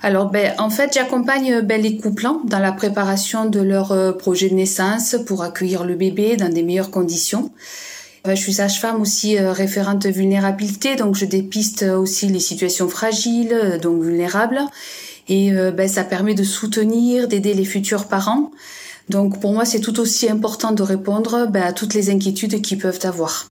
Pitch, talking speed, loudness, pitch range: 200 Hz, 175 wpm, -18 LUFS, 190-225 Hz